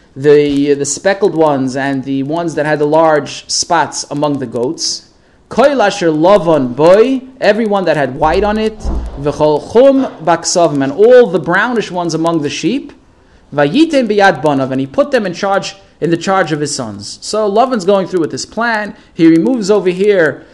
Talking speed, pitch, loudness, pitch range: 170 wpm, 170 Hz, -12 LUFS, 145-210 Hz